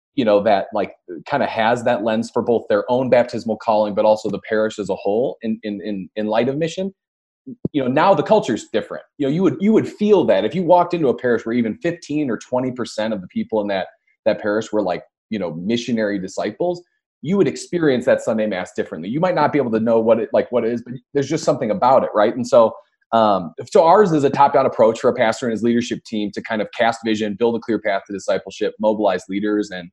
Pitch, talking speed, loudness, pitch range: 115 Hz, 250 wpm, -19 LUFS, 105-140 Hz